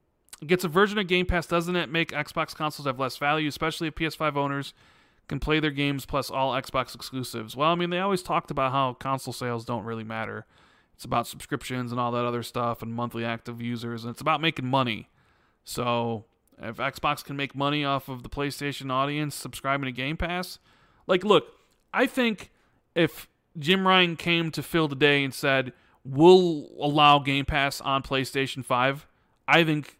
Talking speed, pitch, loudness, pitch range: 190 wpm, 140 Hz, -26 LUFS, 125-160 Hz